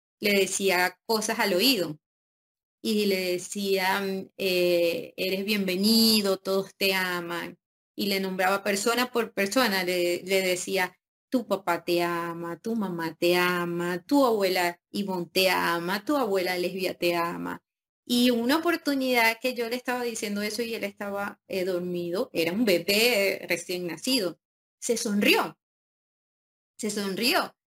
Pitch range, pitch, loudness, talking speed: 180-225 Hz, 195 Hz, -26 LUFS, 140 wpm